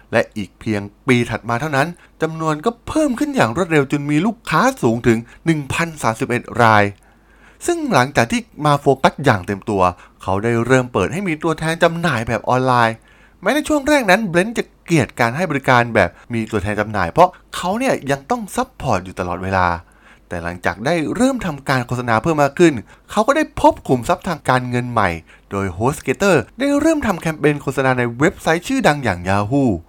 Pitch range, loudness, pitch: 110-175 Hz, -18 LUFS, 135 Hz